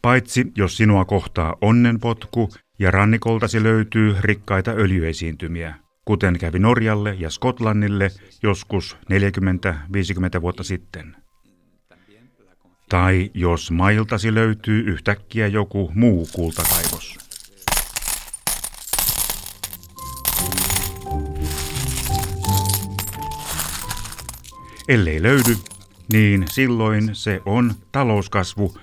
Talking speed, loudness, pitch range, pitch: 70 wpm, -20 LUFS, 90-110 Hz, 100 Hz